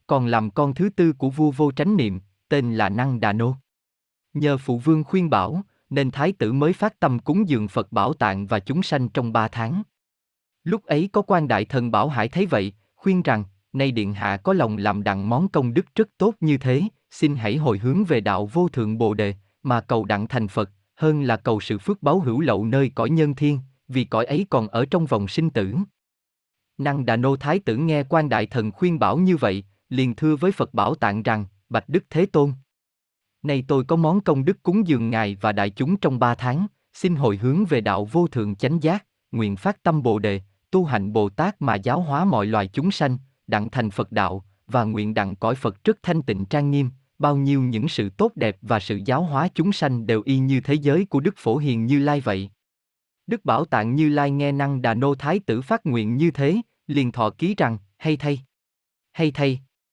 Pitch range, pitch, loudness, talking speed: 110-155 Hz, 135 Hz, -22 LUFS, 225 wpm